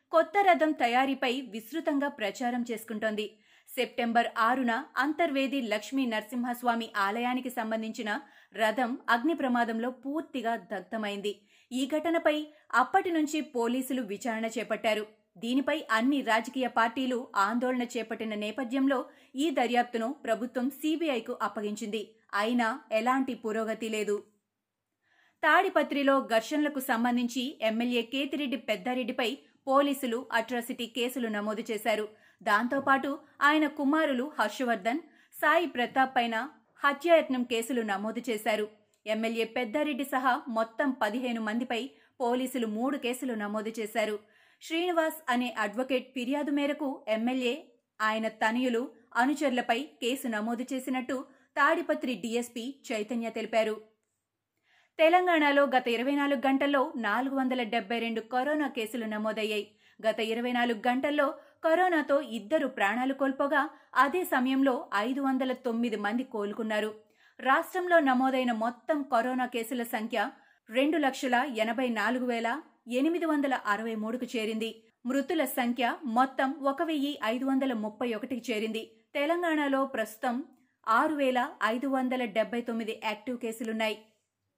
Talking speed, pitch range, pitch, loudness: 110 wpm, 225-275 Hz, 245 Hz, -30 LUFS